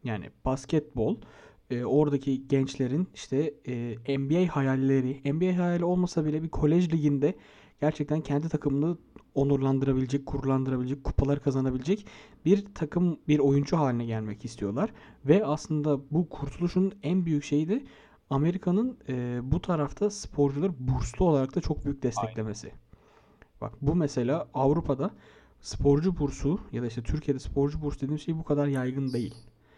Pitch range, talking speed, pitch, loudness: 135-160 Hz, 135 wpm, 145 Hz, -28 LUFS